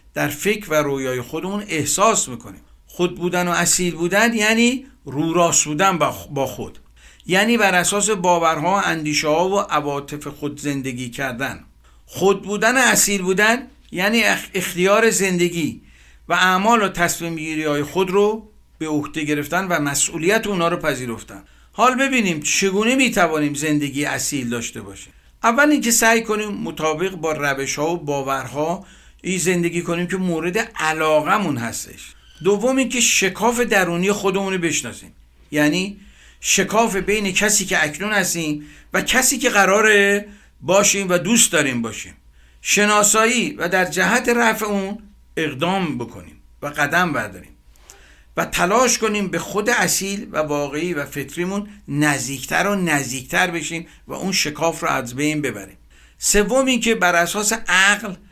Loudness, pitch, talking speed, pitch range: -18 LUFS, 175 Hz, 145 wpm, 145-205 Hz